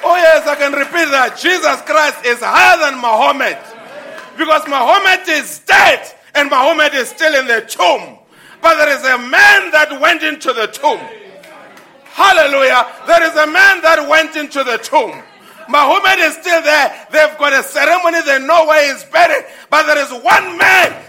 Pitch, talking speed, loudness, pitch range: 305 Hz, 175 wpm, -11 LUFS, 275-325 Hz